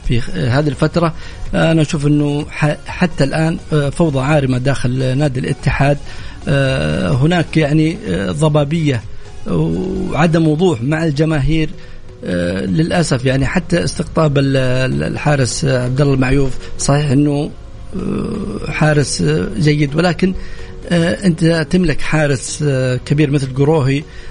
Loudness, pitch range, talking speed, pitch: -15 LUFS, 135-160 Hz, 95 wpm, 150 Hz